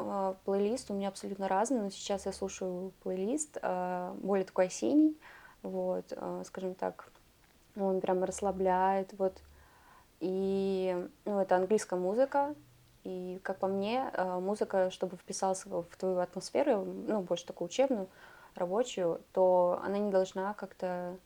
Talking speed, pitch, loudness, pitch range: 125 wpm, 190 Hz, -33 LUFS, 185-200 Hz